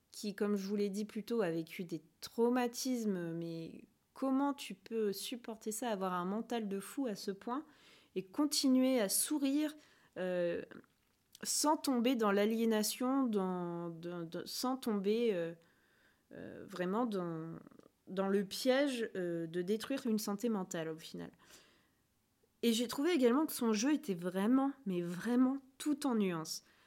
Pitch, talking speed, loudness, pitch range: 215 Hz, 155 wpm, -36 LUFS, 185-255 Hz